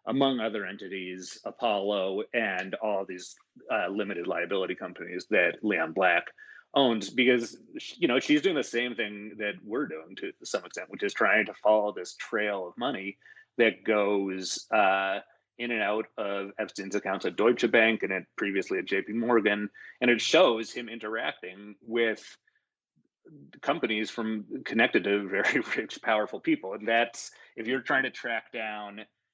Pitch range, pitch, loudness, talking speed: 100-120 Hz, 110 Hz, -28 LUFS, 160 wpm